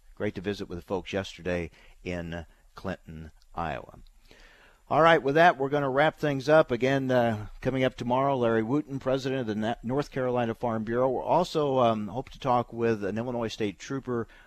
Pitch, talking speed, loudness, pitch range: 120 Hz, 185 wpm, -27 LUFS, 105-135 Hz